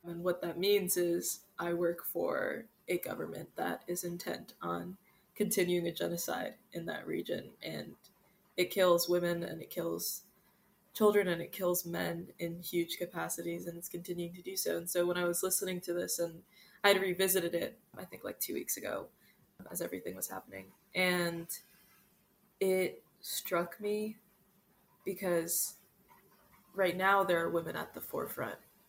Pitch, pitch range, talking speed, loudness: 180 Hz, 170-195 Hz, 160 wpm, -35 LUFS